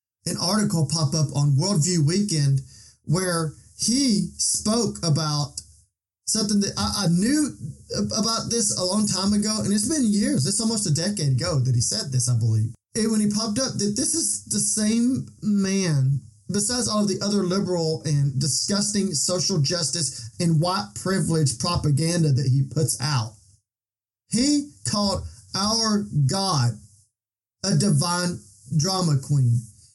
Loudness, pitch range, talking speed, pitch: -23 LUFS, 130-205 Hz, 150 wpm, 170 Hz